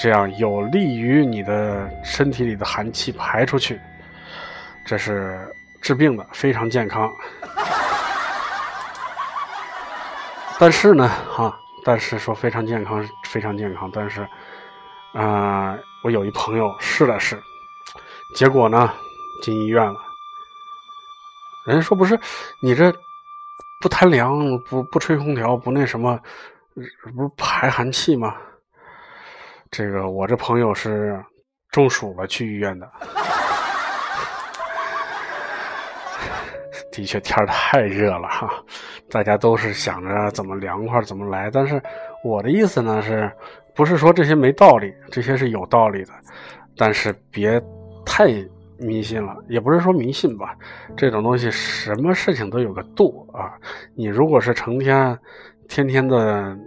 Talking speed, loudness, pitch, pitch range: 190 characters per minute, -19 LUFS, 120 Hz, 105-150 Hz